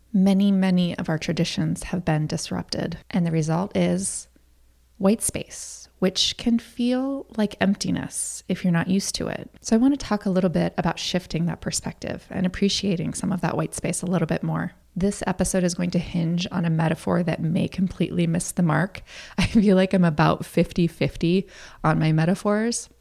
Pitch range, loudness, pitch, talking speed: 170-195 Hz, -24 LUFS, 180 Hz, 190 wpm